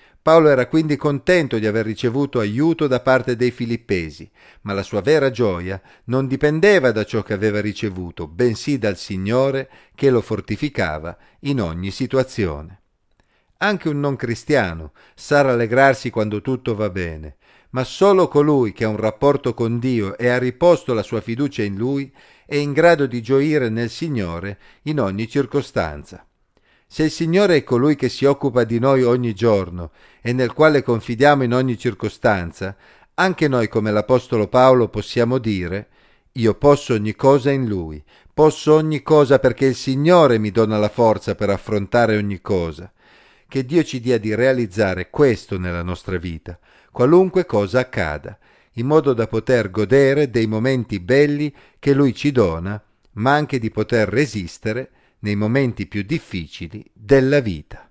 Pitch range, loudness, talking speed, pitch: 105-140 Hz, -18 LUFS, 160 wpm, 120 Hz